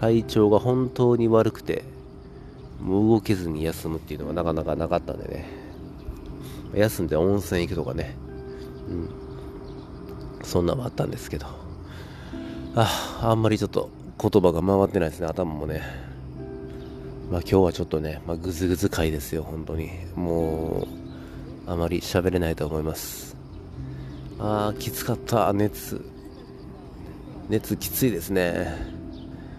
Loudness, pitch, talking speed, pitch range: -25 LUFS, 80 Hz, 275 characters per minute, 70-95 Hz